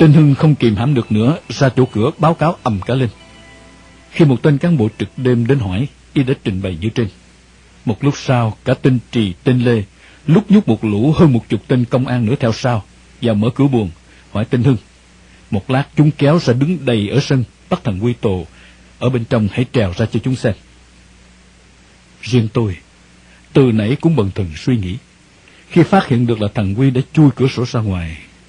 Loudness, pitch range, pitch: -15 LUFS, 95-135 Hz, 120 Hz